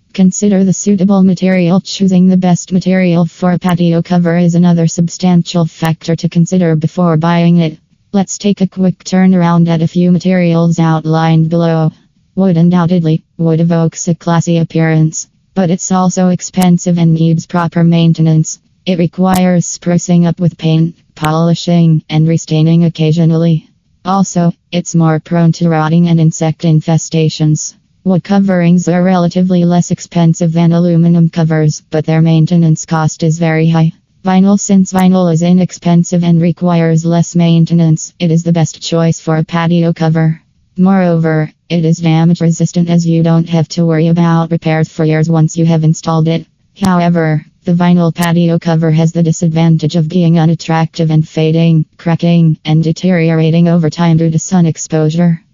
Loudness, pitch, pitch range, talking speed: -11 LUFS, 170 Hz, 160-175 Hz, 155 wpm